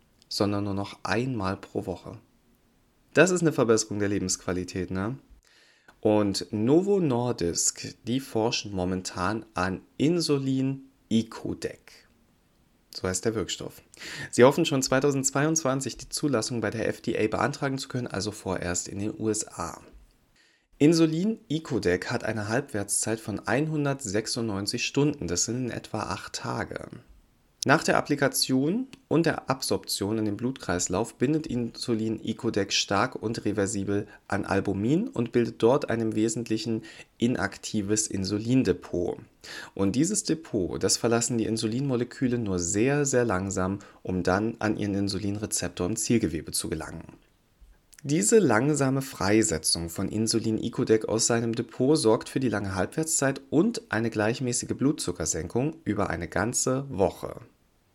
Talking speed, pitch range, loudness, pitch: 125 wpm, 100-130 Hz, -27 LUFS, 110 Hz